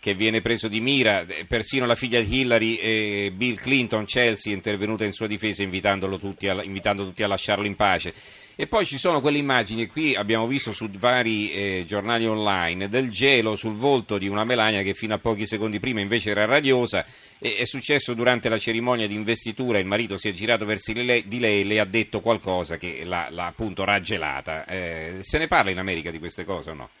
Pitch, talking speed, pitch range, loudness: 110 Hz, 210 wpm, 100-120 Hz, -23 LUFS